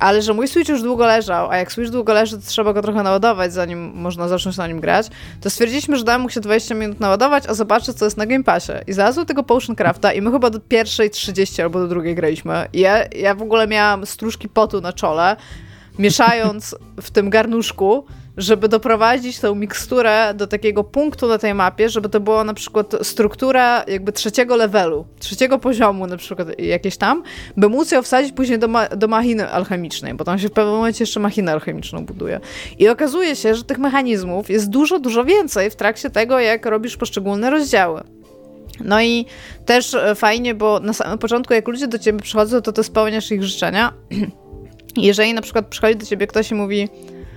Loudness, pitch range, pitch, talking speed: -17 LUFS, 200-235 Hz, 215 Hz, 200 wpm